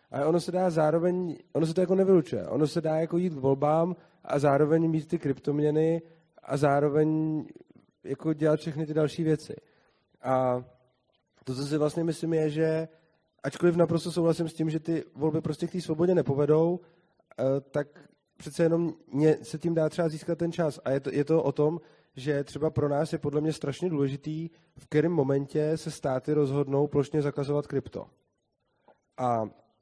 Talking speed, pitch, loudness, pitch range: 175 wpm, 155 Hz, -28 LUFS, 145-165 Hz